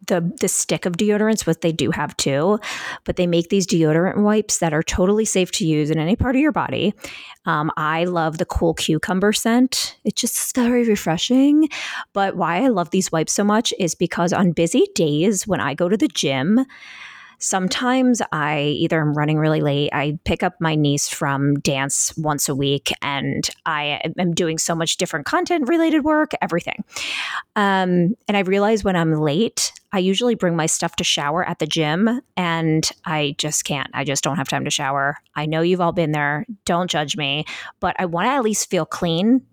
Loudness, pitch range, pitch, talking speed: -20 LUFS, 155-210 Hz, 175 Hz, 195 wpm